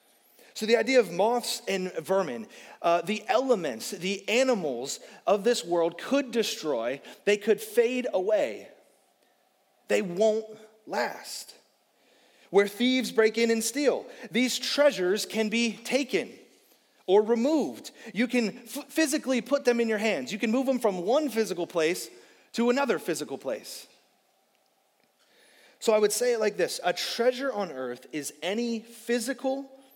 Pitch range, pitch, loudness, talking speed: 205-255 Hz, 230 Hz, -27 LUFS, 145 wpm